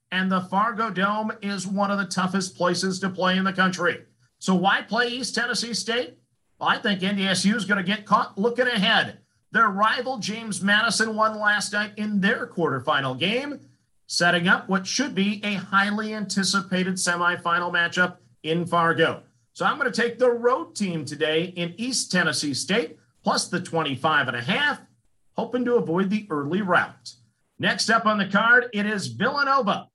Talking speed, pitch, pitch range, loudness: 175 wpm, 195 Hz, 175-220 Hz, -23 LUFS